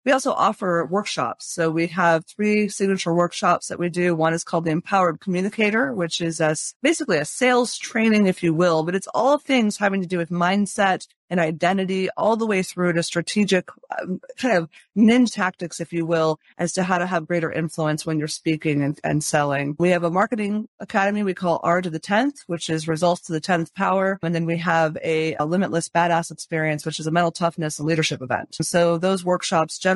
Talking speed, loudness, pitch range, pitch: 210 wpm, -22 LUFS, 165-195 Hz, 175 Hz